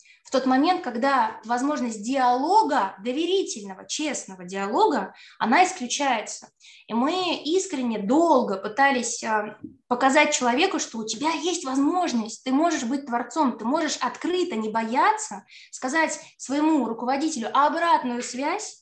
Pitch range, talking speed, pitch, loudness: 240-315 Hz, 120 wpm, 270 Hz, -24 LUFS